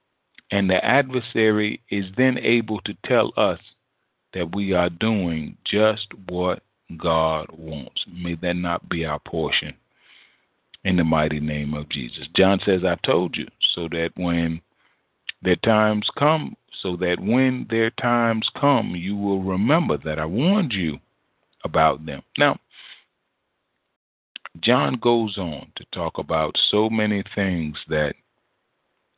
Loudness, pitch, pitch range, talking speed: -22 LUFS, 95 Hz, 85-110 Hz, 135 wpm